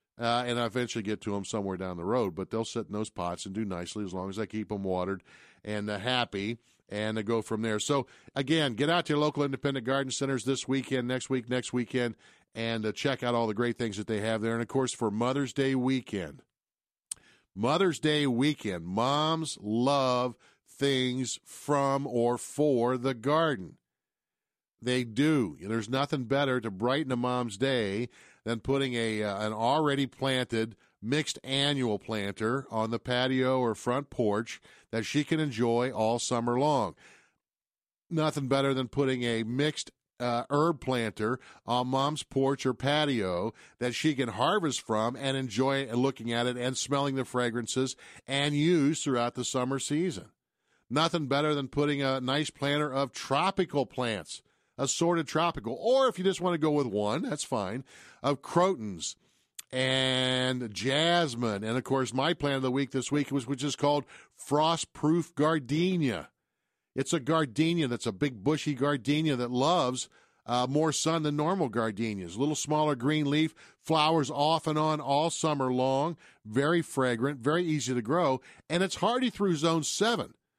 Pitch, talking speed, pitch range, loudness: 130 Hz, 175 wpm, 120-145 Hz, -29 LUFS